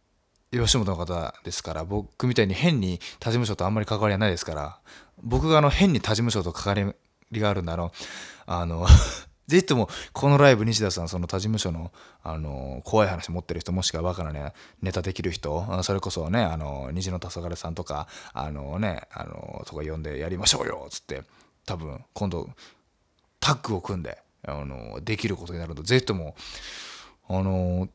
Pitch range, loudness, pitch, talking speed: 80-110 Hz, -26 LUFS, 90 Hz, 350 characters per minute